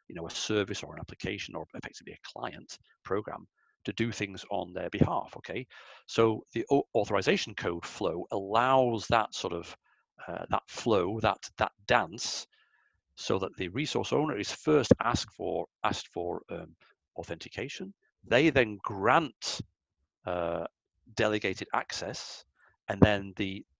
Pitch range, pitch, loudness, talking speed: 90-115 Hz, 105 Hz, -31 LUFS, 140 wpm